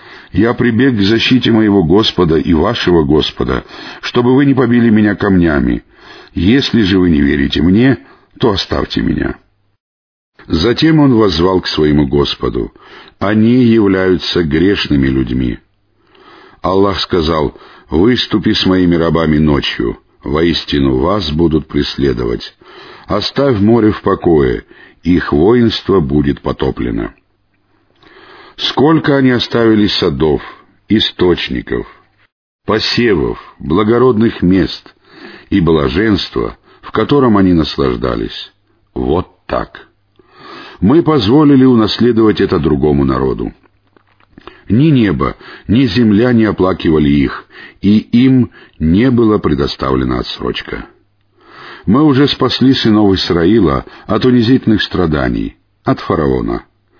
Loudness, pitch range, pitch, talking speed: -12 LUFS, 80-120 Hz, 100 Hz, 105 wpm